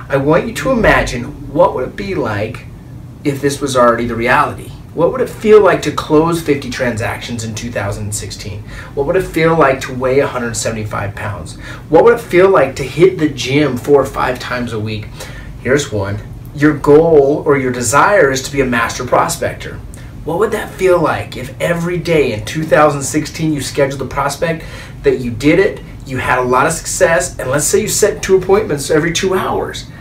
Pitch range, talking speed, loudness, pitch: 120-155 Hz, 195 wpm, -14 LUFS, 135 Hz